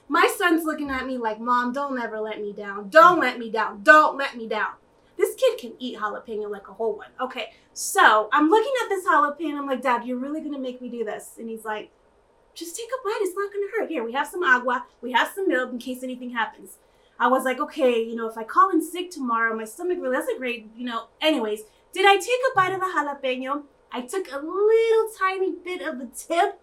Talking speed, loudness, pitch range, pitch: 240 wpm, -23 LUFS, 240-380 Hz, 290 Hz